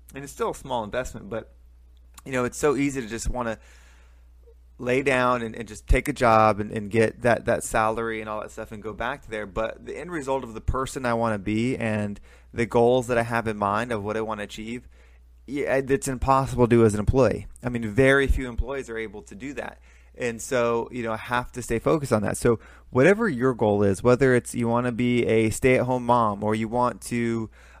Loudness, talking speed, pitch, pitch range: -24 LUFS, 240 wpm, 115 Hz, 105-125 Hz